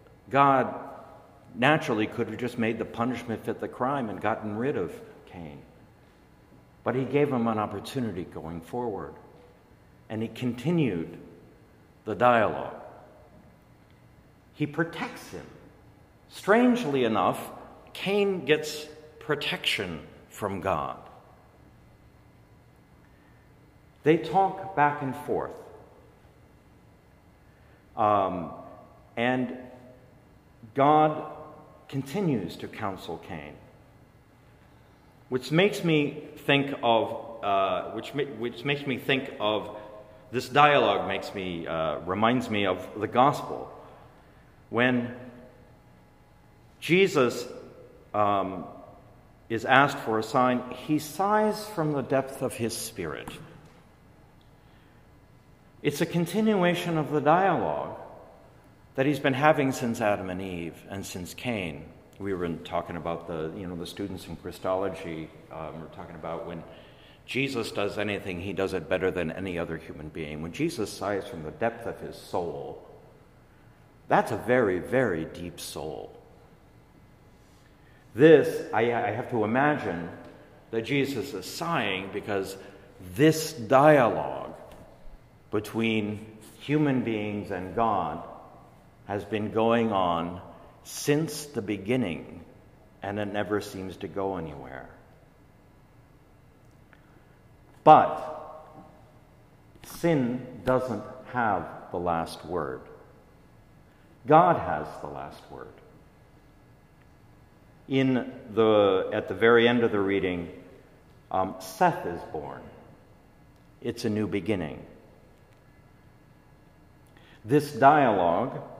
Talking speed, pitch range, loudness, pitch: 110 wpm, 100-145 Hz, -27 LUFS, 115 Hz